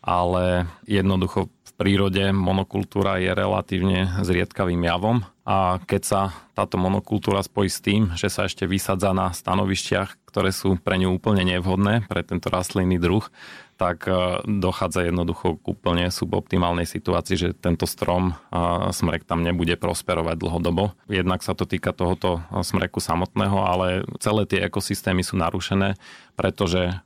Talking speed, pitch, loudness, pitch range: 140 wpm, 95 Hz, -23 LUFS, 90-100 Hz